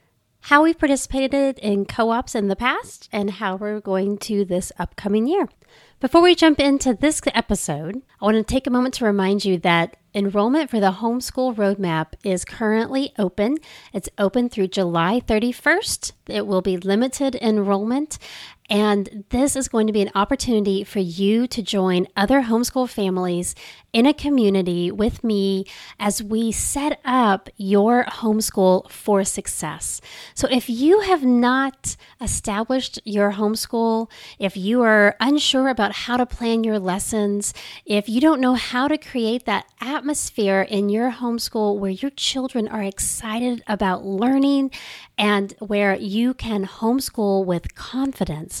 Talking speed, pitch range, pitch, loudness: 150 wpm, 200-255 Hz, 220 Hz, -20 LUFS